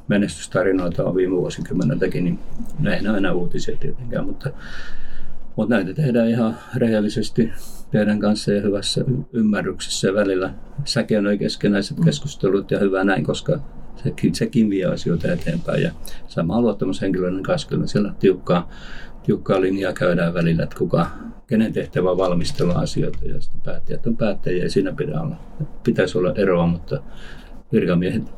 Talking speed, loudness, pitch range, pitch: 145 wpm, -21 LUFS, 85-105 Hz, 95 Hz